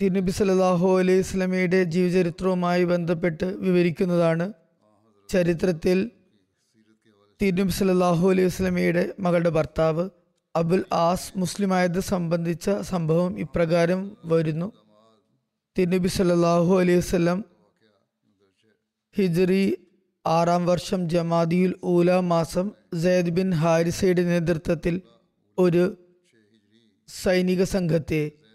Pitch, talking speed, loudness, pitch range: 180 Hz, 70 wpm, -23 LUFS, 170-185 Hz